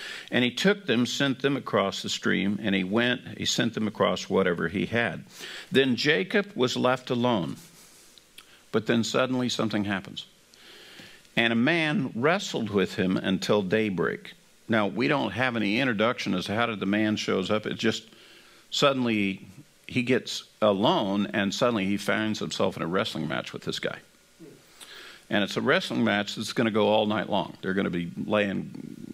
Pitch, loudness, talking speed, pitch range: 115 Hz, -26 LUFS, 175 wpm, 105-125 Hz